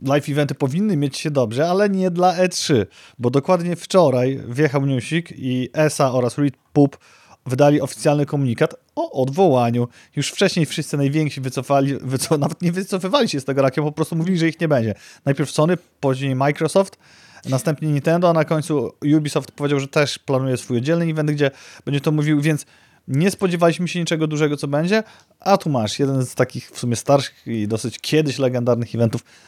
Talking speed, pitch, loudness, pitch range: 175 wpm, 145 Hz, -20 LUFS, 135-165 Hz